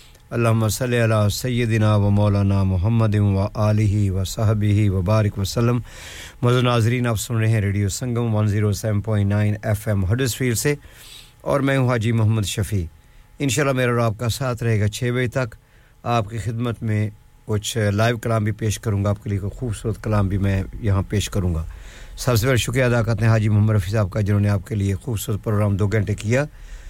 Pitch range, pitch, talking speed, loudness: 105-120 Hz, 110 Hz, 215 wpm, -21 LUFS